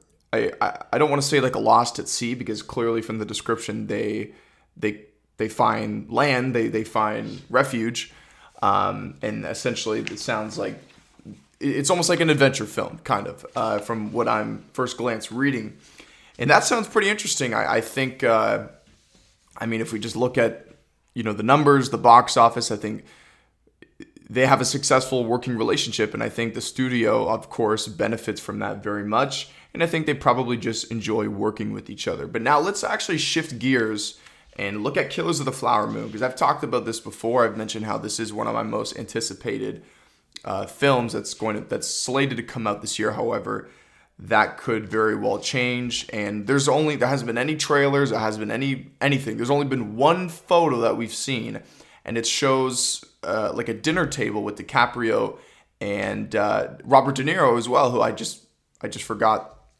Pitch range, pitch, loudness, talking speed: 110-140 Hz, 120 Hz, -23 LUFS, 195 wpm